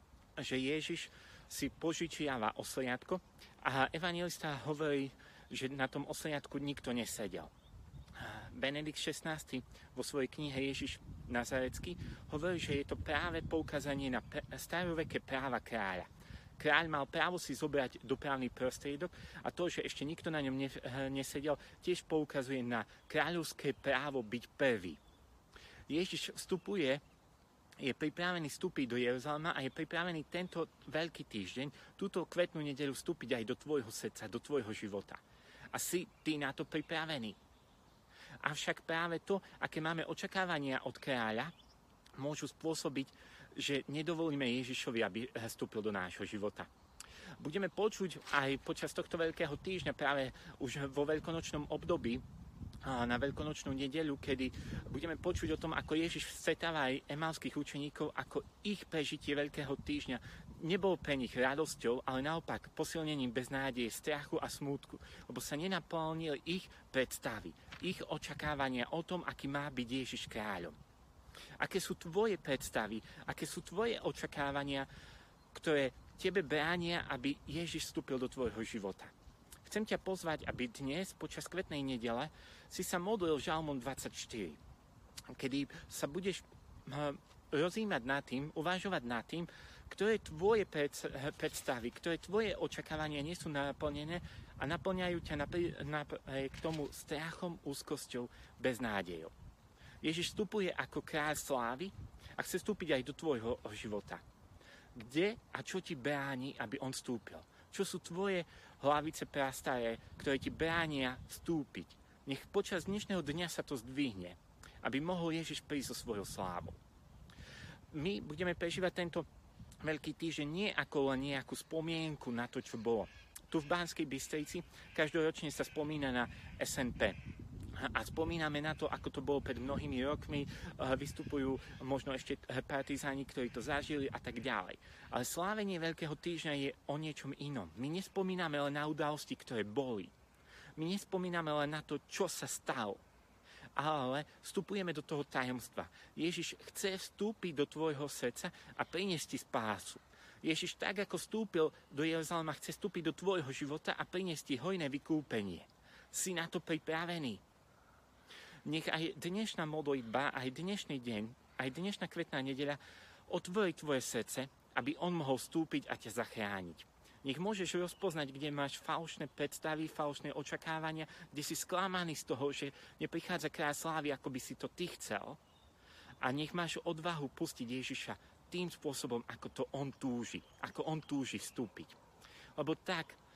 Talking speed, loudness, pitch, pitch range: 140 wpm, -40 LUFS, 150 Hz, 130-165 Hz